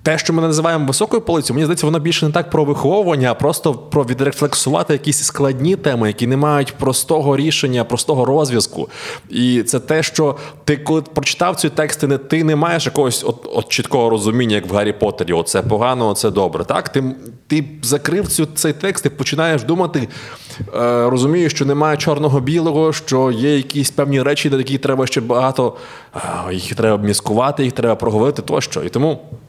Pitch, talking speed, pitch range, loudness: 145 Hz, 175 wpm, 125-155 Hz, -16 LUFS